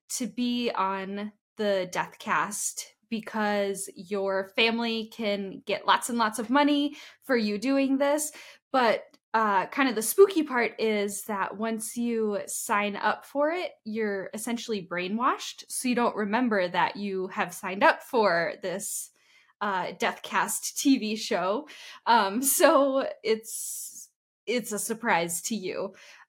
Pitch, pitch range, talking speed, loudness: 225 Hz, 205-255 Hz, 140 wpm, -27 LUFS